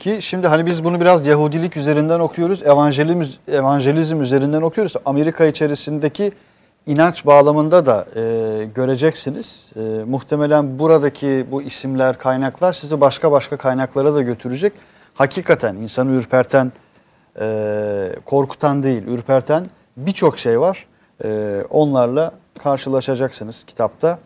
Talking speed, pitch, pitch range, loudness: 110 wpm, 145 Hz, 130-160 Hz, -17 LUFS